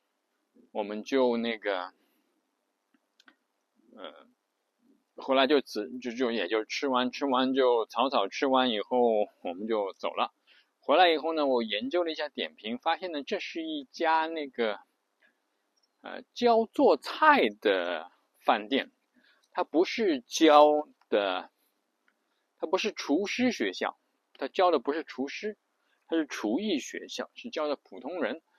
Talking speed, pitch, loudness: 190 characters per minute, 150 Hz, -28 LUFS